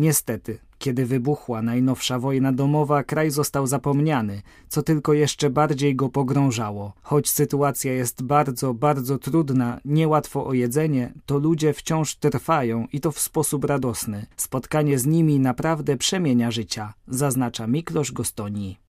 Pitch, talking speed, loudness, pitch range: 140 Hz, 135 wpm, -22 LUFS, 120-150 Hz